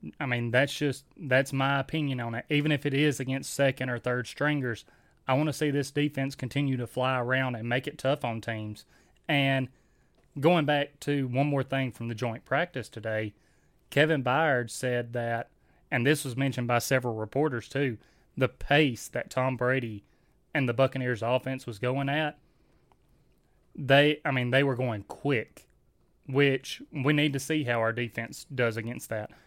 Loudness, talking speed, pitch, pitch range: -28 LUFS, 175 wpm, 130 Hz, 120-145 Hz